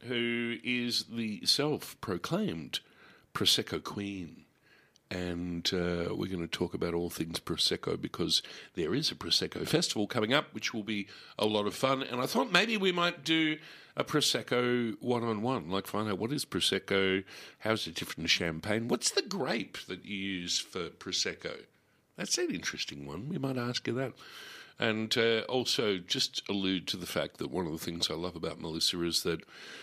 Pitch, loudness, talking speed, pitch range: 105 Hz, -32 LUFS, 185 wpm, 90-125 Hz